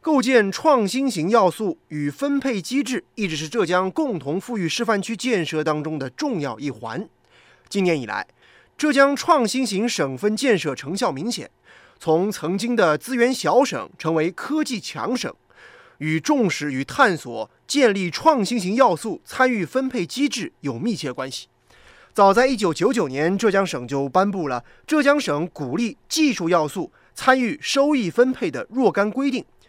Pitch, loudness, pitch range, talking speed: 220 Hz, -21 LUFS, 165-260 Hz, 240 characters per minute